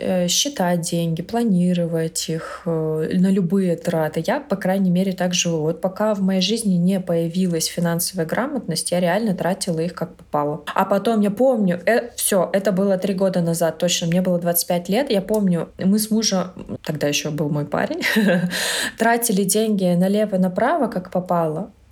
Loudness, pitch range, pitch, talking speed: -20 LUFS, 170-200 Hz, 185 Hz, 165 wpm